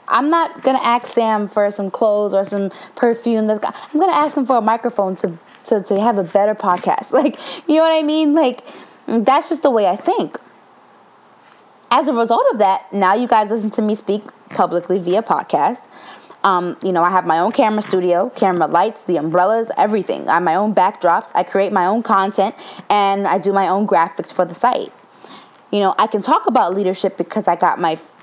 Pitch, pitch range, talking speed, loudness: 205 Hz, 190-240 Hz, 210 wpm, -17 LUFS